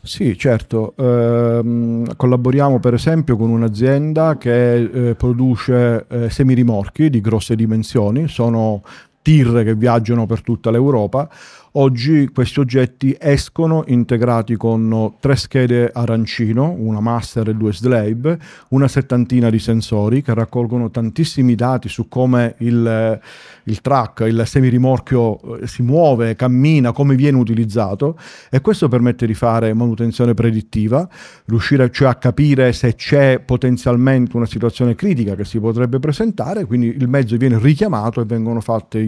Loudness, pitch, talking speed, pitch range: -15 LUFS, 120 Hz, 135 wpm, 115-135 Hz